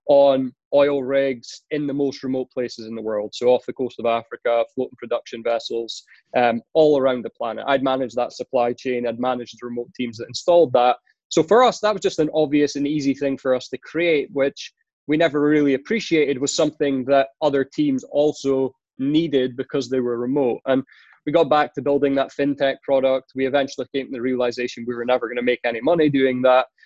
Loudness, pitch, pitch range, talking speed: -21 LUFS, 135 Hz, 125-145 Hz, 210 wpm